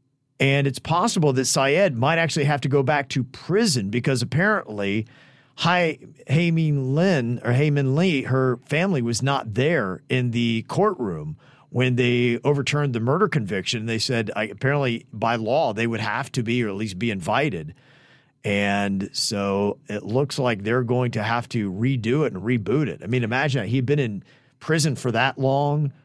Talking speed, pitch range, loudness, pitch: 180 wpm, 115-145 Hz, -22 LUFS, 130 Hz